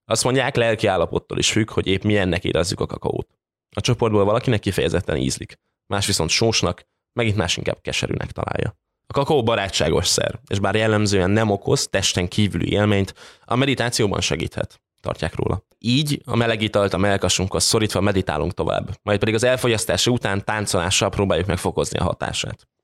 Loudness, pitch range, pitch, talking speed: -21 LUFS, 95-115 Hz, 105 Hz, 160 wpm